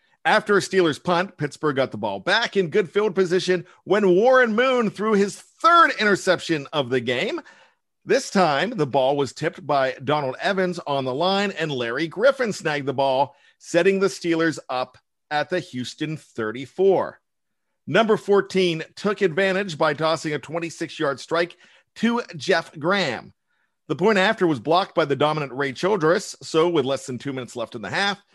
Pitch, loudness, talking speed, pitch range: 170 Hz, -22 LUFS, 175 wpm, 145-195 Hz